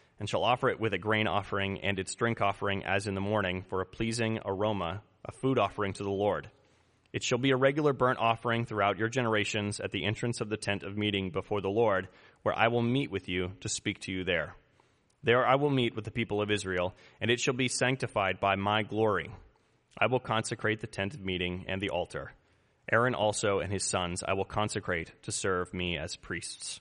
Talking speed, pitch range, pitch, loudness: 220 wpm, 95-115 Hz, 105 Hz, -31 LUFS